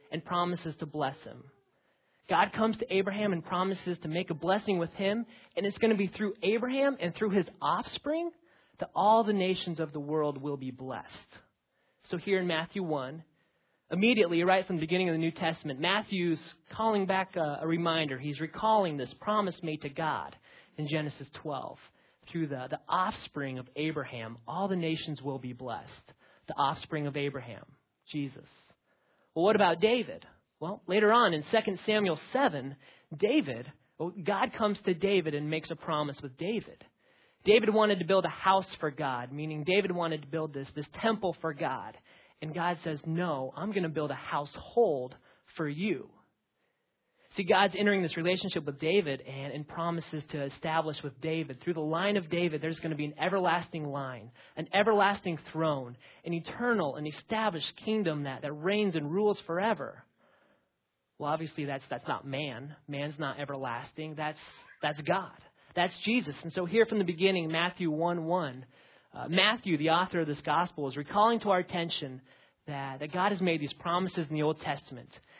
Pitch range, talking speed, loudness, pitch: 150-195 Hz, 175 wpm, -31 LUFS, 165 Hz